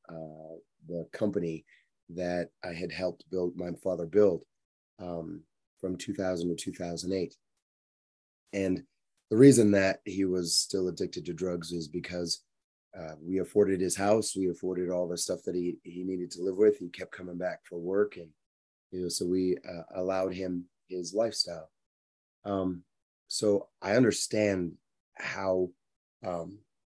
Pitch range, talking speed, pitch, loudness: 85-95 Hz, 150 wpm, 90 Hz, -30 LUFS